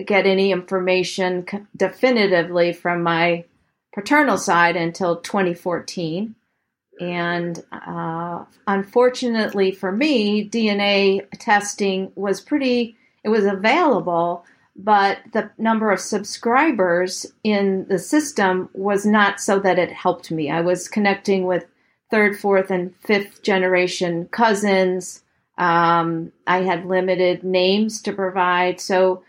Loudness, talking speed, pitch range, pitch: -19 LUFS, 115 wpm, 180-205 Hz, 190 Hz